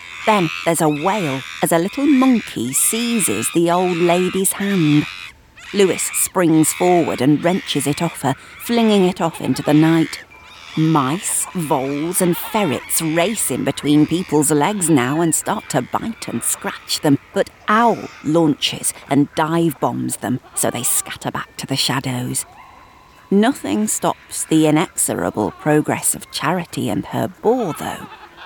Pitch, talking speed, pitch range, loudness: 160 Hz, 145 wpm, 145-180 Hz, -18 LUFS